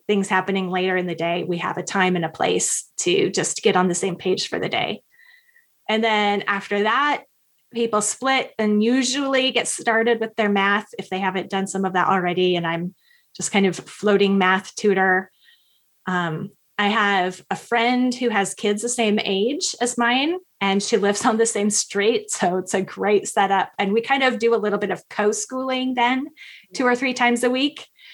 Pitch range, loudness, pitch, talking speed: 190-240 Hz, -21 LUFS, 210 Hz, 200 wpm